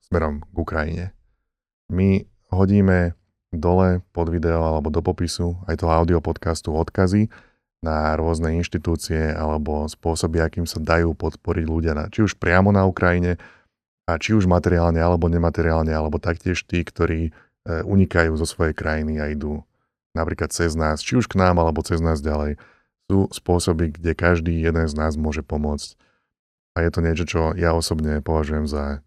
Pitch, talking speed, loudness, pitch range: 85 Hz, 160 wpm, -21 LUFS, 80-90 Hz